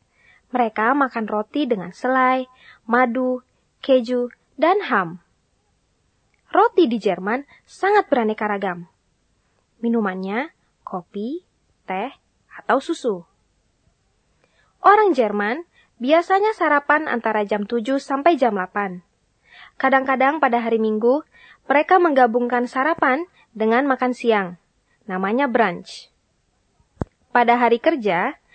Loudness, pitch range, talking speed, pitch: -20 LUFS, 220-285 Hz, 95 wpm, 250 Hz